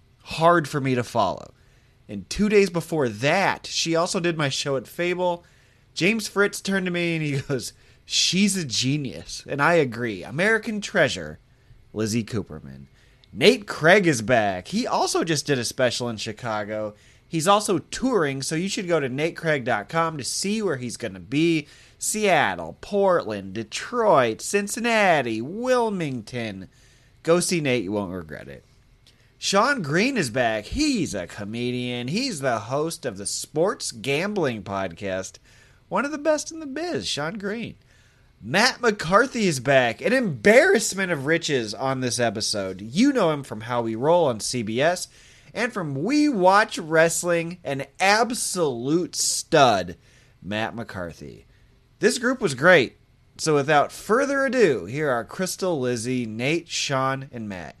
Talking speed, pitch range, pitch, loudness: 150 wpm, 120-190 Hz, 140 Hz, -23 LUFS